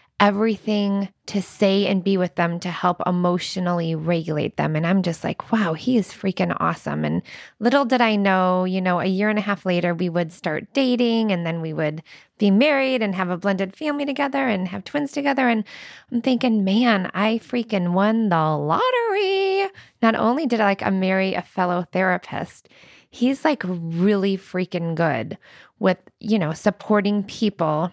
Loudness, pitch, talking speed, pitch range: -21 LUFS, 195 Hz, 175 wpm, 180-225 Hz